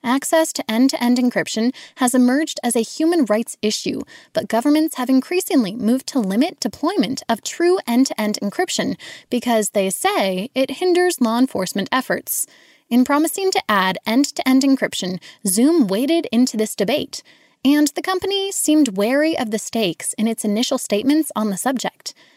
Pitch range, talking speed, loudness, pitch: 225-310 Hz, 170 wpm, -19 LUFS, 260 Hz